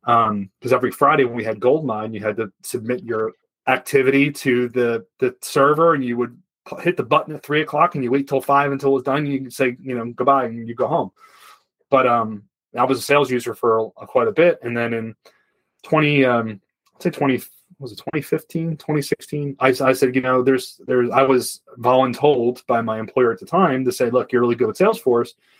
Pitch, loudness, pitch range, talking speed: 130 Hz, -19 LUFS, 120-140 Hz, 220 wpm